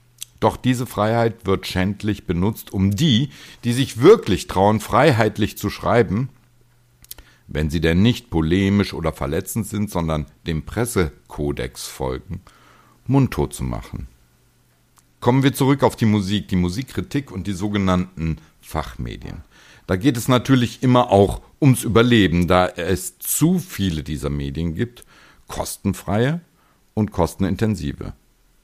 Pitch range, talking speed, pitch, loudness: 80-120 Hz, 125 wpm, 100 Hz, -20 LUFS